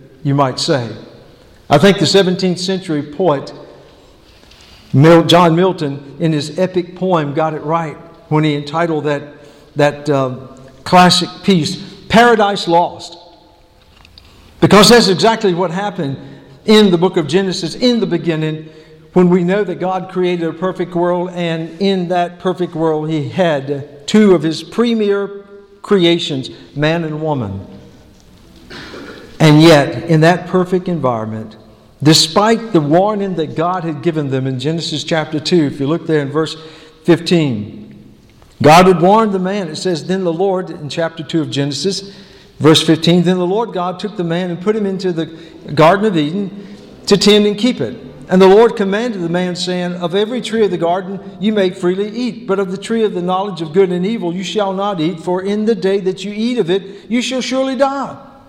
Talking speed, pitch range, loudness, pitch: 175 wpm, 155-195 Hz, -14 LUFS, 175 Hz